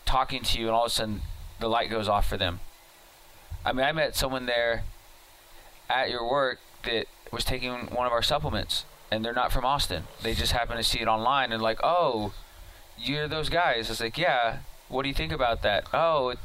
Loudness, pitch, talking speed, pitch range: -27 LUFS, 115 Hz, 210 wpm, 105-125 Hz